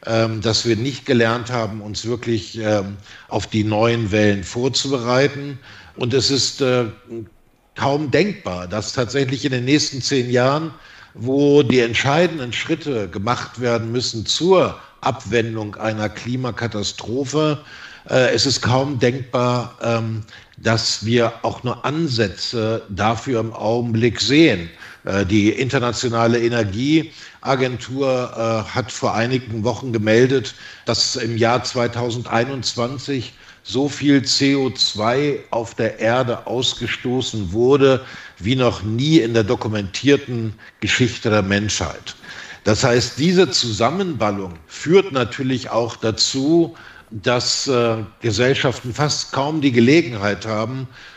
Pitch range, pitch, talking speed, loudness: 110-135 Hz, 120 Hz, 115 wpm, -19 LUFS